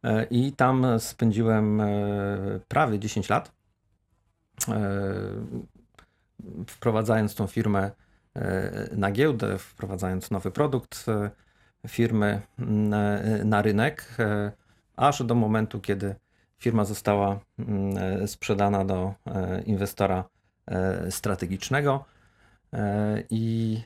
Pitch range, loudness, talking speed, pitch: 100-115 Hz, -27 LUFS, 70 wpm, 105 Hz